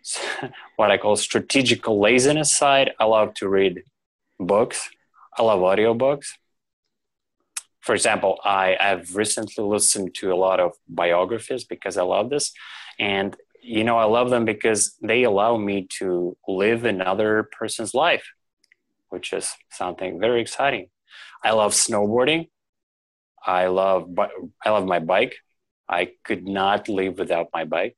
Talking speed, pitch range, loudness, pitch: 135 wpm, 95-115 Hz, -21 LUFS, 105 Hz